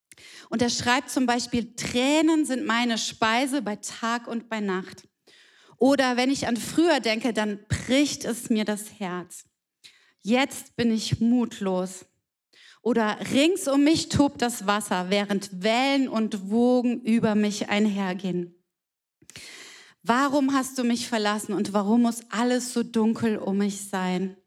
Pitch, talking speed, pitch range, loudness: 230 Hz, 140 wpm, 205-250 Hz, -25 LUFS